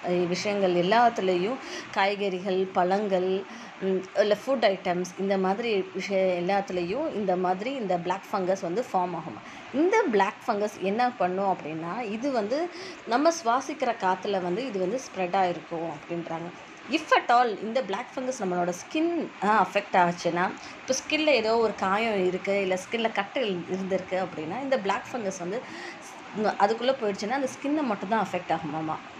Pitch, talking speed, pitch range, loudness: 195 Hz, 140 wpm, 185-235 Hz, -27 LUFS